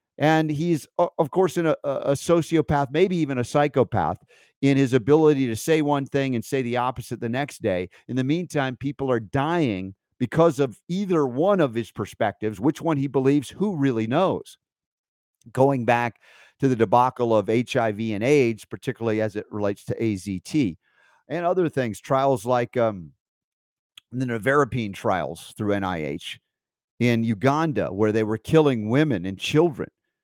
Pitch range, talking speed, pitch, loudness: 115-150 Hz, 160 wpm, 130 Hz, -23 LUFS